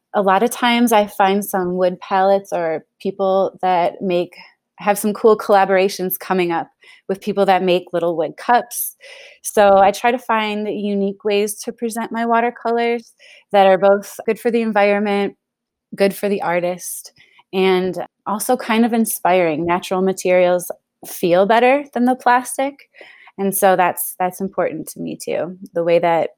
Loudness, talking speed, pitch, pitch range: -17 LUFS, 160 wpm, 200 Hz, 185-230 Hz